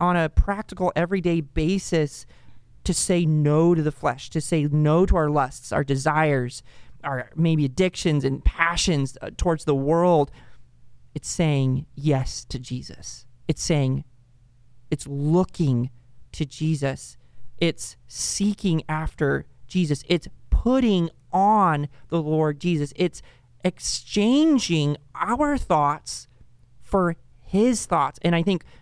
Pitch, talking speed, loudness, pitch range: 155 Hz, 125 wpm, -23 LUFS, 135-175 Hz